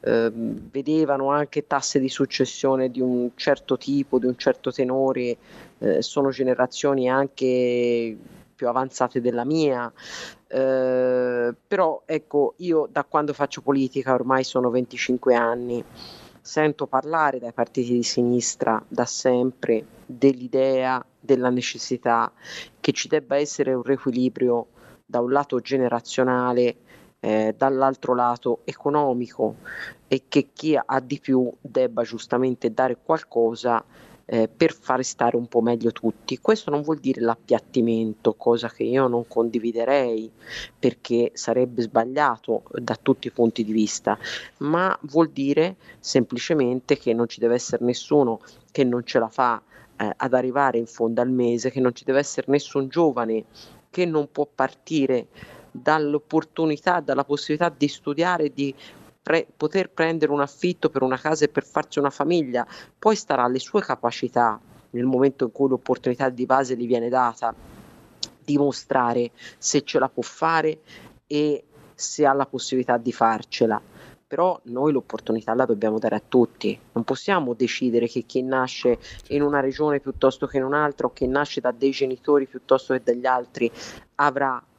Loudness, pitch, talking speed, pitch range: -23 LUFS, 130 Hz, 150 wpm, 120-140 Hz